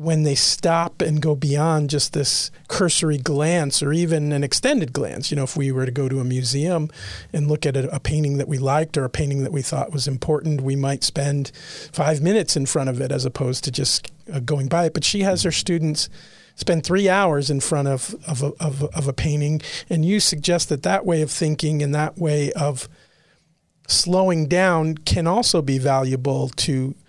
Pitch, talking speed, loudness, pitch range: 150 Hz, 210 wpm, -21 LUFS, 140-165 Hz